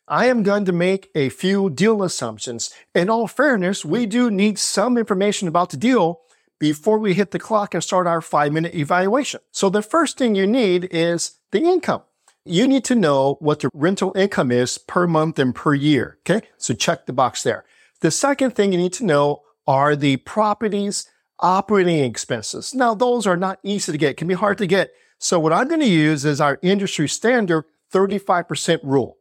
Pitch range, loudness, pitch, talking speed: 155-210 Hz, -19 LUFS, 185 Hz, 195 wpm